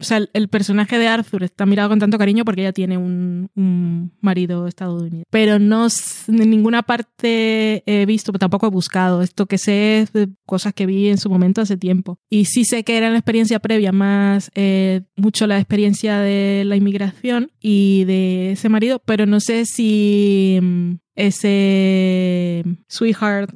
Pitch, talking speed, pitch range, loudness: 200 Hz, 170 wpm, 190-215 Hz, -17 LUFS